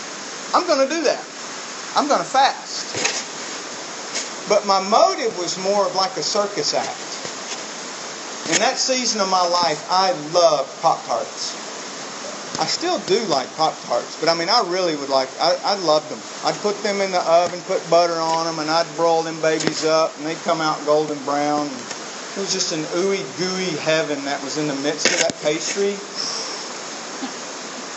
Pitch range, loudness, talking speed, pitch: 155-195 Hz, -21 LUFS, 170 wpm, 170 Hz